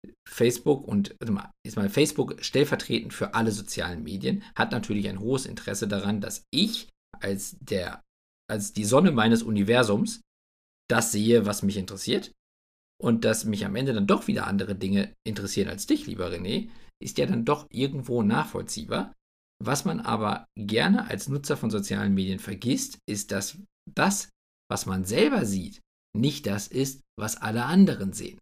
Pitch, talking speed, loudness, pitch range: 105 Hz, 160 wpm, -27 LUFS, 100-135 Hz